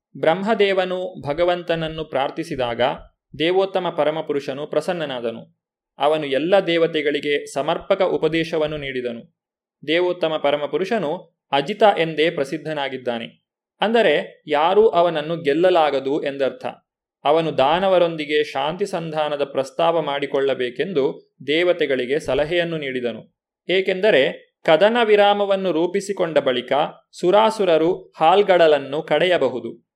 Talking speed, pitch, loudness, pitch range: 80 wpm, 165 Hz, -20 LUFS, 145-185 Hz